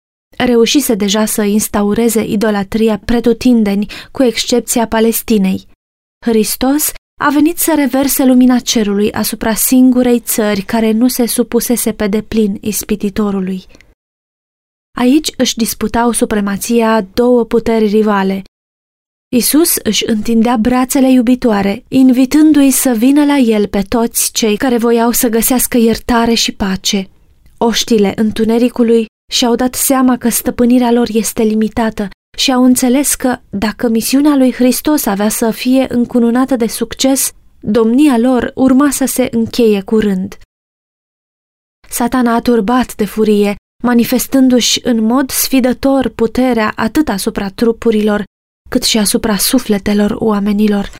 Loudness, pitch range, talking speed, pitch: -12 LUFS, 215-255 Hz, 120 wpm, 235 Hz